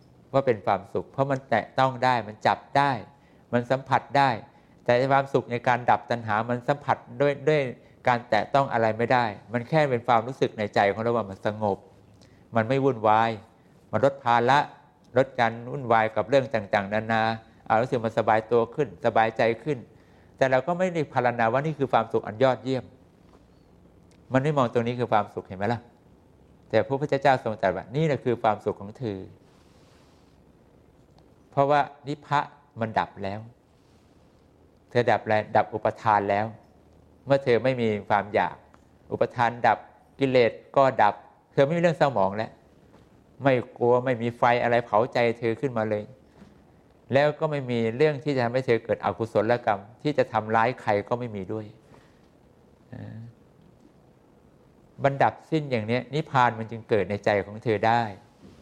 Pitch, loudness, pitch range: 120 Hz, -25 LUFS, 110-135 Hz